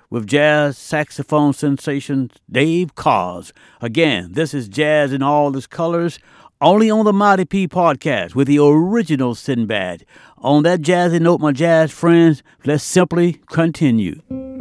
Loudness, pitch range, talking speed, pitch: -16 LUFS, 145-175 Hz, 140 wpm, 150 Hz